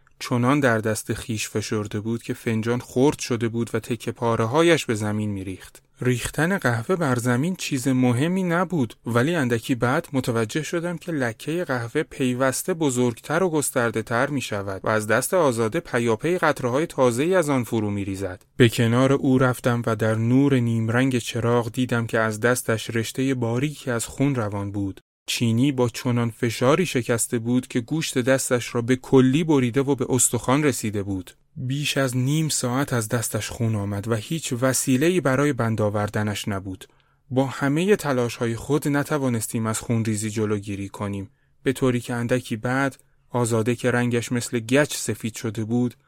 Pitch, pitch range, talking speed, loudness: 125 Hz, 115-135 Hz, 170 wpm, -23 LUFS